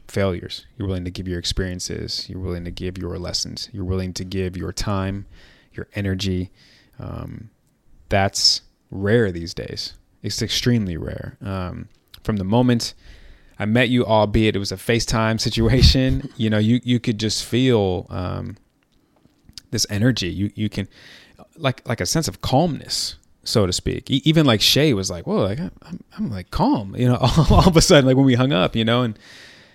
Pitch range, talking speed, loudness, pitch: 95-120 Hz, 180 wpm, -20 LUFS, 105 Hz